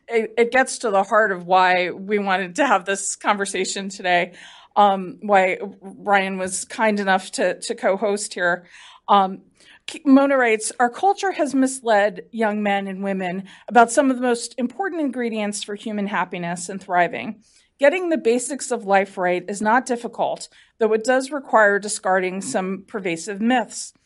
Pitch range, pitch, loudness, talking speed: 195-245 Hz, 210 Hz, -20 LUFS, 165 wpm